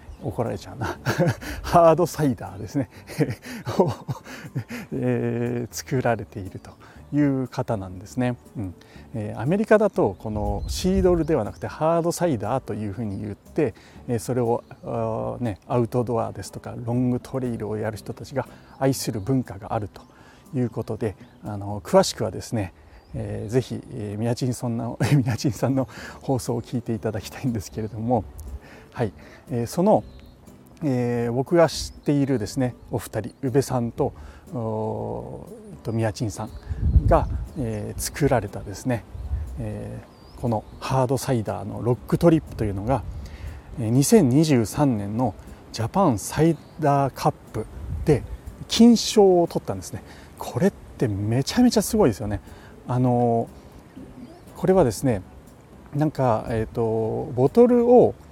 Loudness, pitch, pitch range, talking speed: -24 LUFS, 120 Hz, 105-135 Hz, 290 characters per minute